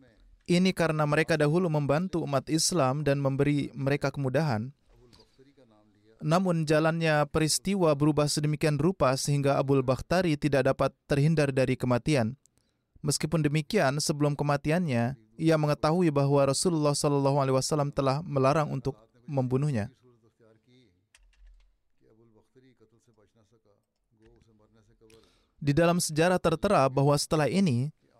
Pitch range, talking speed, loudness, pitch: 125-155 Hz, 100 wpm, -27 LUFS, 140 Hz